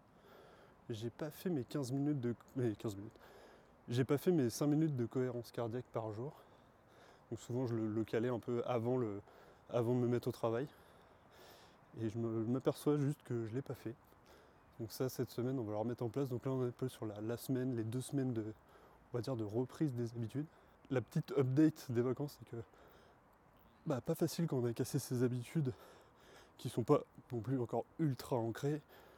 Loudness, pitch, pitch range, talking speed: -39 LUFS, 125 Hz, 115-140 Hz, 220 wpm